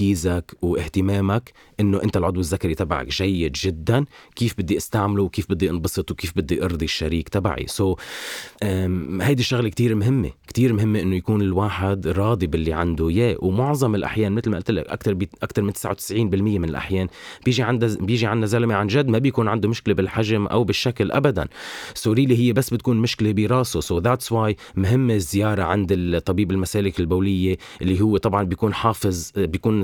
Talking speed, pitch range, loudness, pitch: 170 wpm, 95-115 Hz, -22 LUFS, 100 Hz